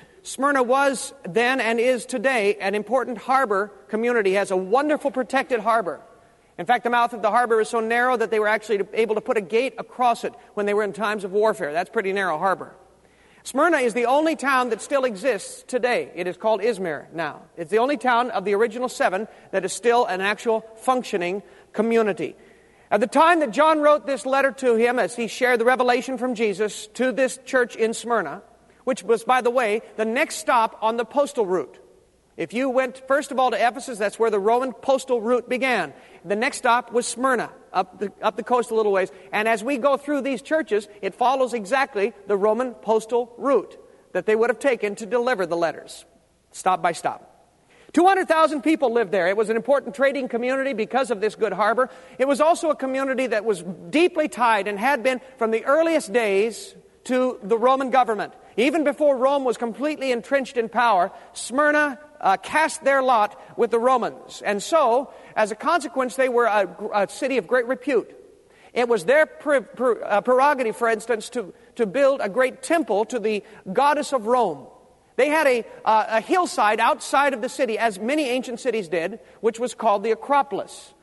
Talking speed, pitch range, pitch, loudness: 200 wpm, 220-270 Hz, 245 Hz, -22 LUFS